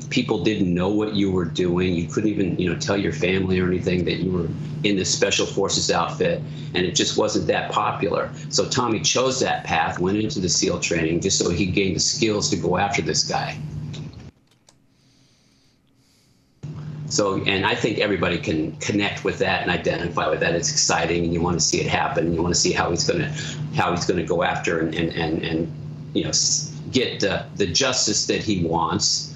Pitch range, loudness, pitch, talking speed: 85-125 Hz, -21 LUFS, 95 Hz, 205 wpm